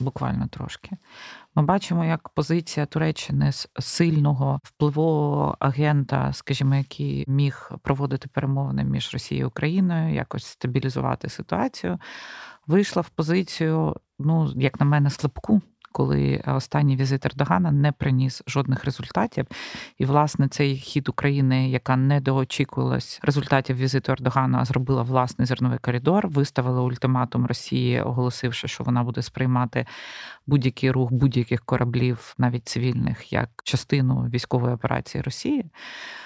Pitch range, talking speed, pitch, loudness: 125-150 Hz, 120 wpm, 135 Hz, -24 LUFS